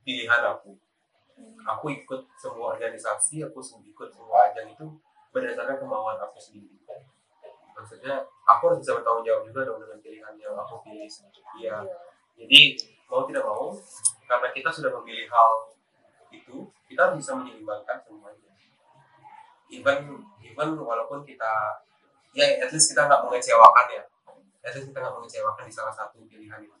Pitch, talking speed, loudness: 155 Hz, 150 wpm, -22 LUFS